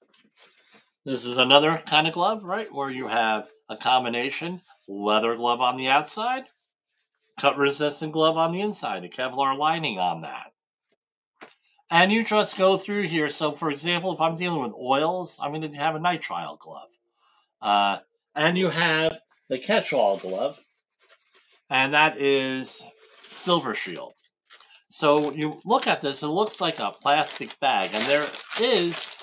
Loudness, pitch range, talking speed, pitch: -24 LUFS, 130-175 Hz, 155 wpm, 150 Hz